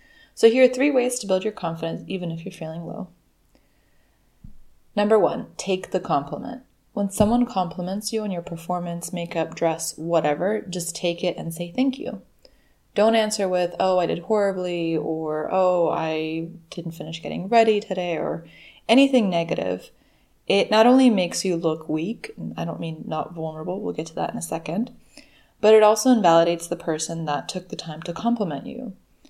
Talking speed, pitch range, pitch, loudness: 180 wpm, 165-215 Hz, 180 Hz, -23 LUFS